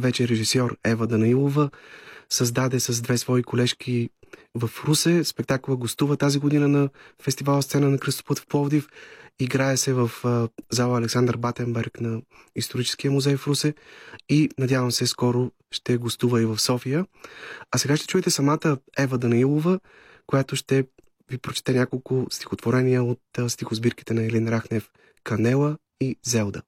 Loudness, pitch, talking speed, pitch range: -24 LUFS, 125 Hz, 145 wpm, 120-140 Hz